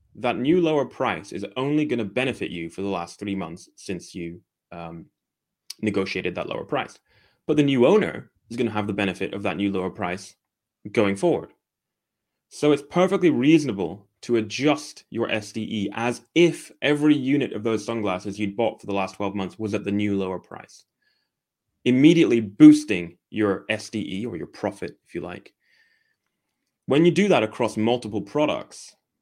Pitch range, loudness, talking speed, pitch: 100-145 Hz, -23 LUFS, 175 wpm, 110 Hz